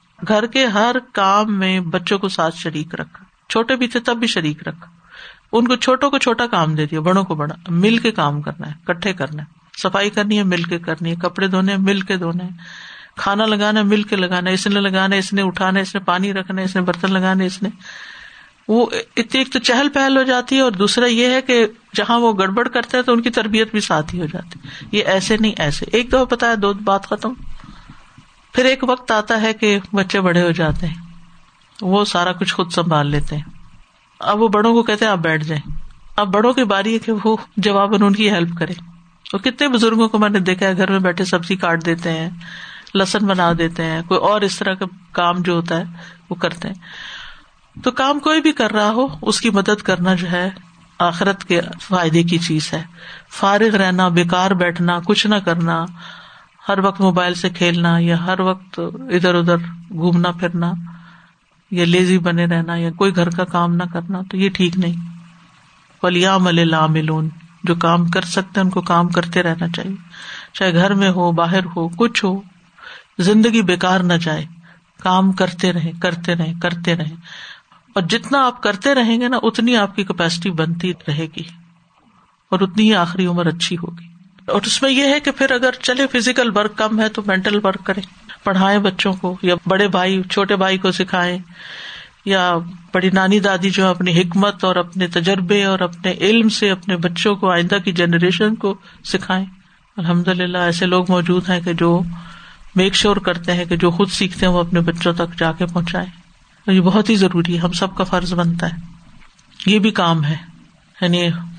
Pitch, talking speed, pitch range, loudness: 185 Hz, 200 wpm, 175-205 Hz, -17 LUFS